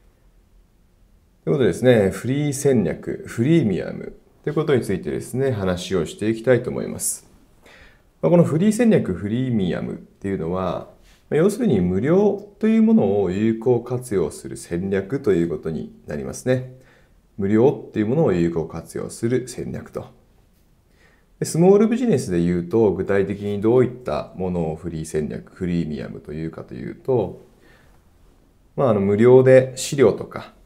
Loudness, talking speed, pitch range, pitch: -20 LUFS, 325 characters per minute, 90-135 Hz, 110 Hz